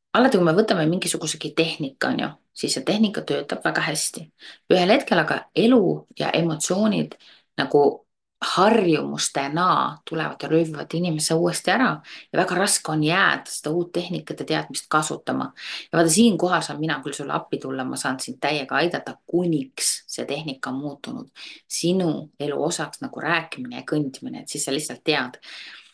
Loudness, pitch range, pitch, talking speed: -22 LUFS, 150-180 Hz, 165 Hz, 160 wpm